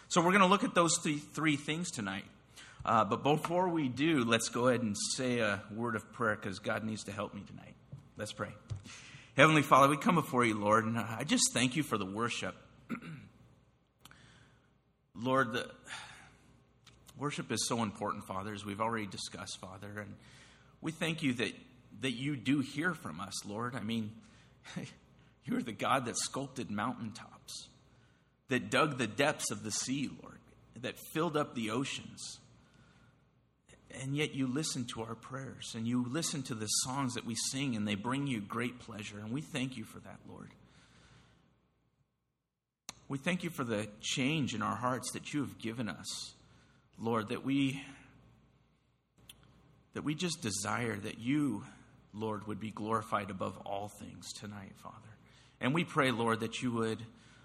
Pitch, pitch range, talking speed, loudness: 120 Hz, 110-140 Hz, 170 wpm, -34 LUFS